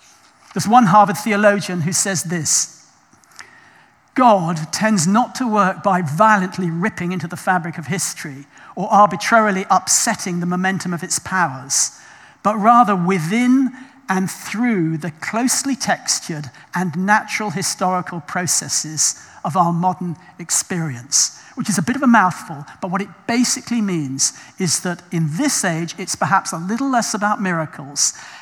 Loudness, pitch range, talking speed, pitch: -18 LUFS, 170-215 Hz, 145 wpm, 190 Hz